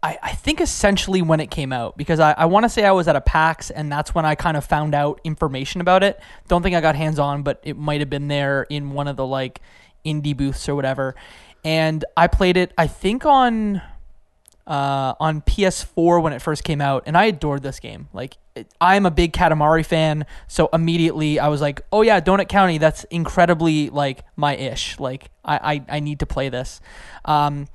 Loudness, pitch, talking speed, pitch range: -19 LUFS, 155 Hz, 215 wpm, 145-170 Hz